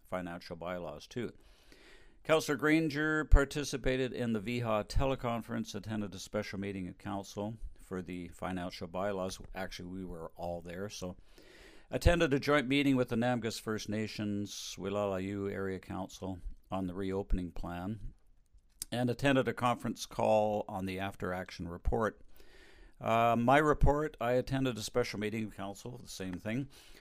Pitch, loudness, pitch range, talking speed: 105 Hz, -34 LUFS, 95-120 Hz, 145 wpm